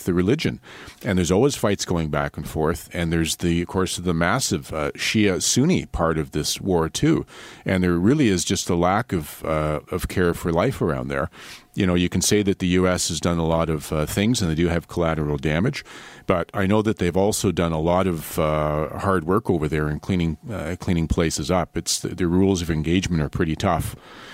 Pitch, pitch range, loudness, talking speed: 85 Hz, 80-95 Hz, -22 LUFS, 225 wpm